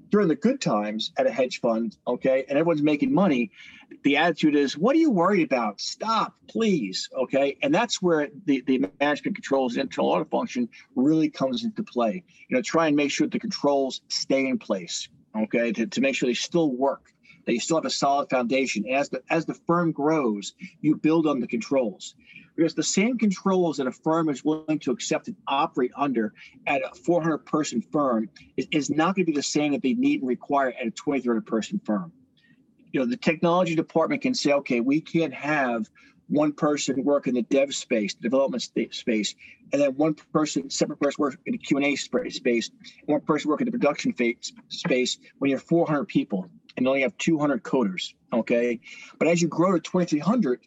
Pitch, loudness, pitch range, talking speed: 155 Hz, -25 LUFS, 135-195 Hz, 200 wpm